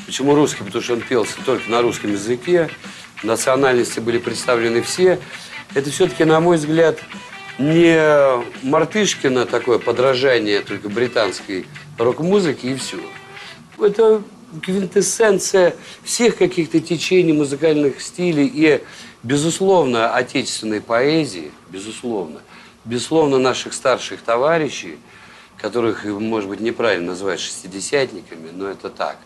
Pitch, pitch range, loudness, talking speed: 145 Hz, 120-175 Hz, -18 LUFS, 110 wpm